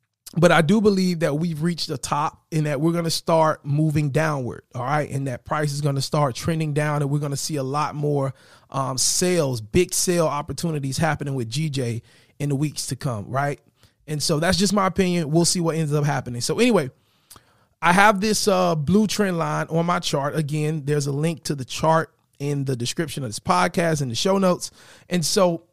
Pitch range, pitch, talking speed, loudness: 140-170 Hz, 150 Hz, 215 wpm, -22 LUFS